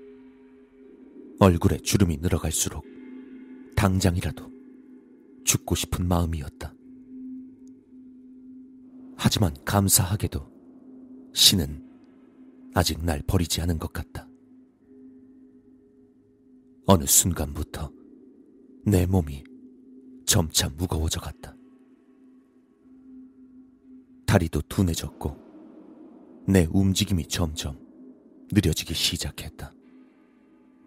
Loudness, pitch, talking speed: -24 LUFS, 130 Hz, 165 characters per minute